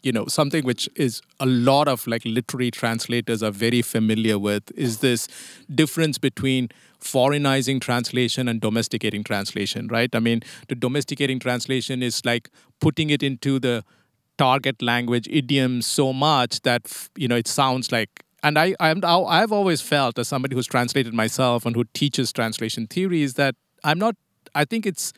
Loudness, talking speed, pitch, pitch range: -22 LUFS, 165 wpm, 125 Hz, 115-140 Hz